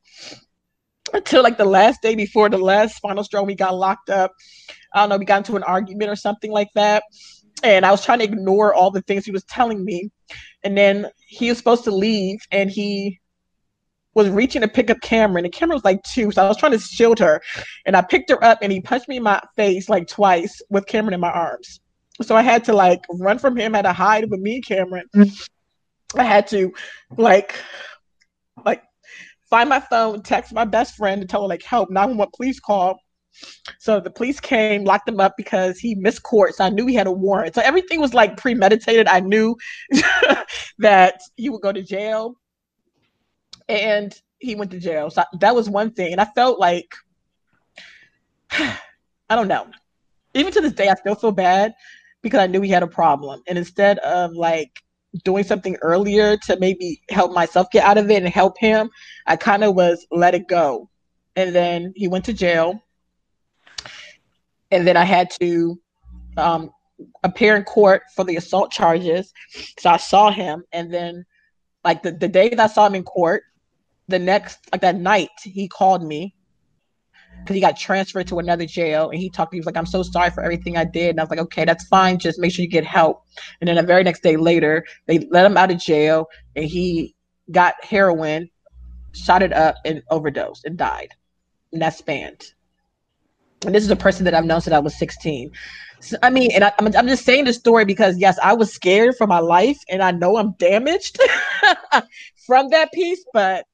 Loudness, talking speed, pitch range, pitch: -17 LUFS, 205 wpm, 175-220 Hz, 195 Hz